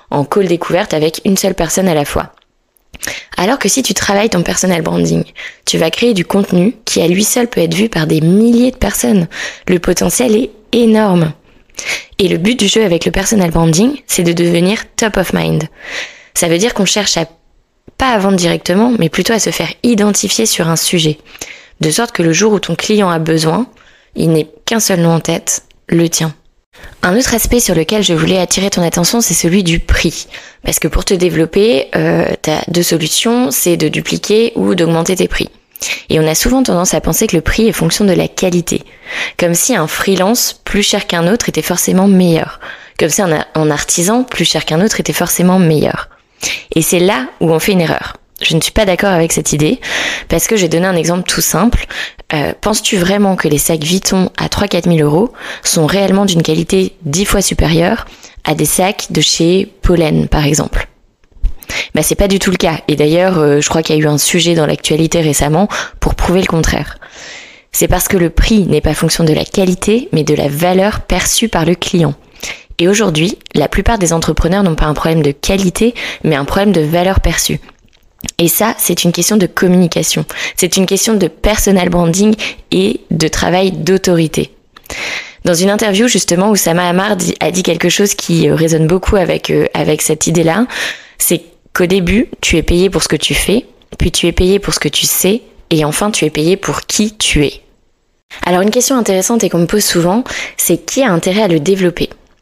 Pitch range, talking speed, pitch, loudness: 165-205 Hz, 205 wpm, 180 Hz, -12 LUFS